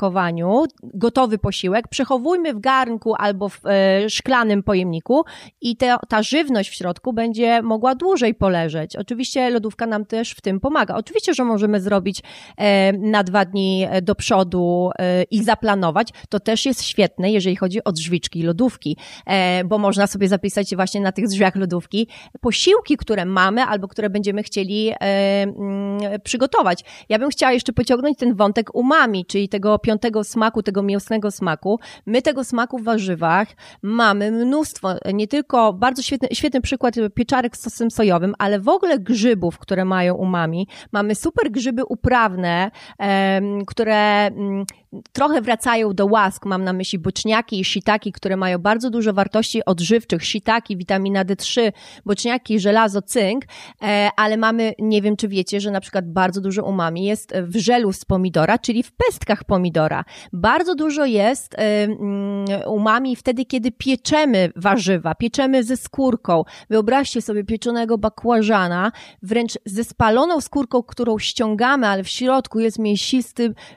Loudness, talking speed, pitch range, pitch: -19 LUFS, 145 wpm, 195-240 Hz, 215 Hz